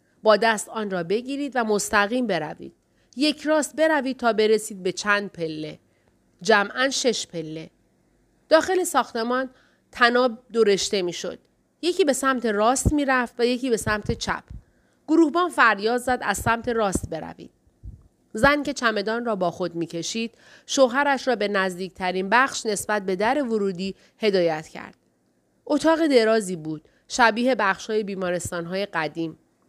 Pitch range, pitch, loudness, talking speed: 190-255 Hz, 220 Hz, -23 LUFS, 135 wpm